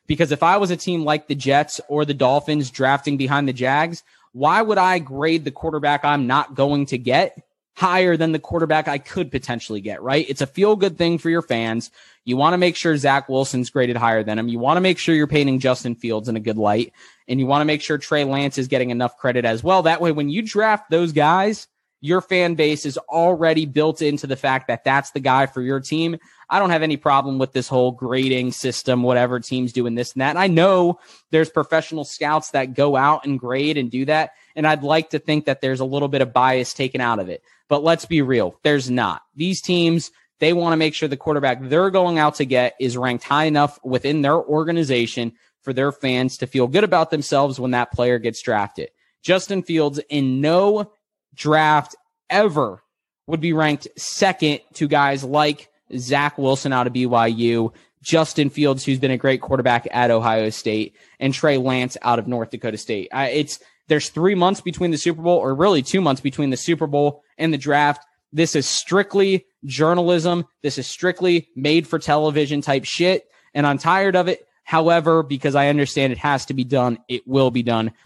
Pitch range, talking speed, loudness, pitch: 130-165 Hz, 215 wpm, -19 LUFS, 145 Hz